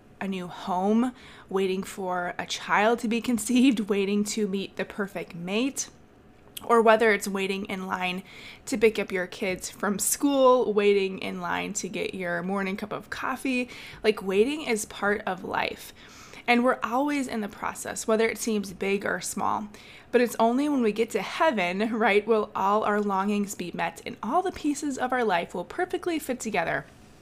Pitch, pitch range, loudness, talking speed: 215 Hz, 195-240 Hz, -26 LUFS, 185 wpm